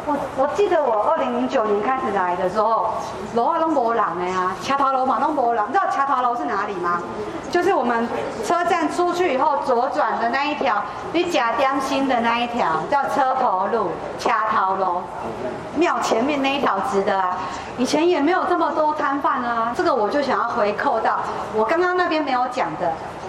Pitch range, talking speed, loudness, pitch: 220-310 Hz, 285 characters per minute, -20 LUFS, 270 Hz